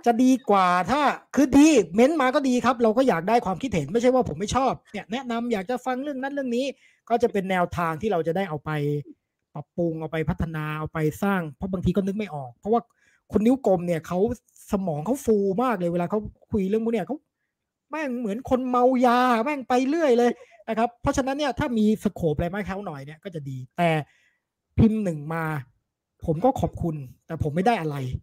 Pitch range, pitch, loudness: 165-250 Hz, 215 Hz, -24 LUFS